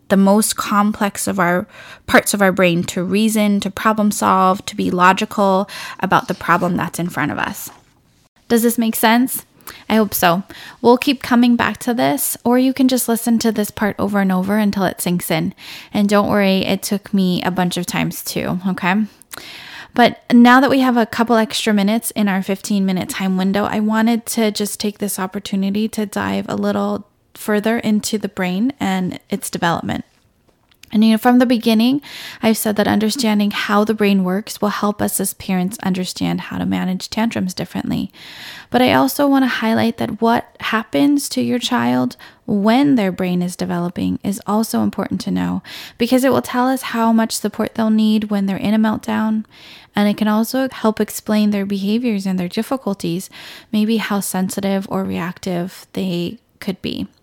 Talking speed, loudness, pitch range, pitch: 190 wpm, -17 LUFS, 190-225 Hz, 210 Hz